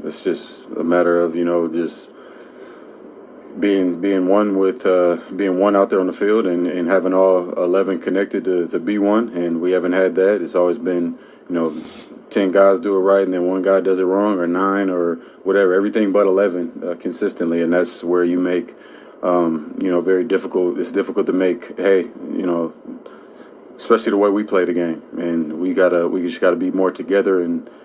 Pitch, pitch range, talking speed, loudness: 90 Hz, 85-95 Hz, 205 wpm, -18 LUFS